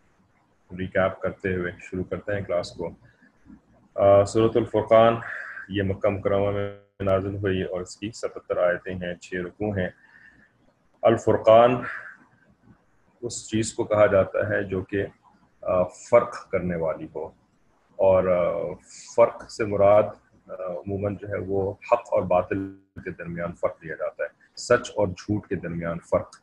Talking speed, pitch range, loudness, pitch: 145 wpm, 90-105 Hz, -24 LUFS, 100 Hz